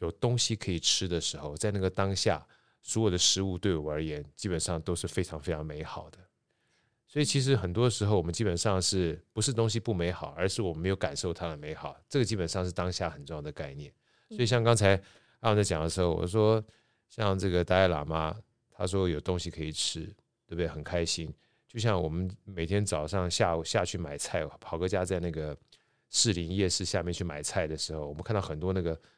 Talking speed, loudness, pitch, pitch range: 325 characters per minute, -30 LUFS, 95 Hz, 85-110 Hz